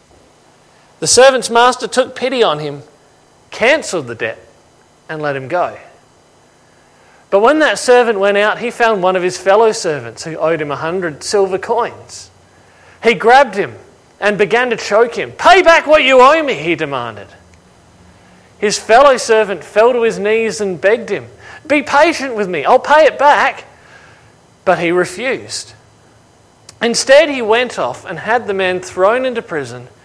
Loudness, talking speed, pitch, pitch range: -13 LUFS, 165 wpm, 205 Hz, 155-240 Hz